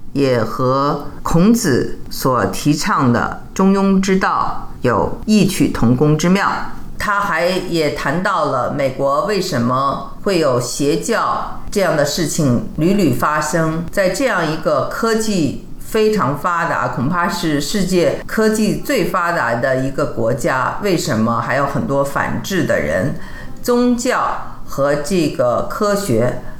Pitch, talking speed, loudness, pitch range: 170 Hz, 195 characters per minute, -17 LUFS, 140-200 Hz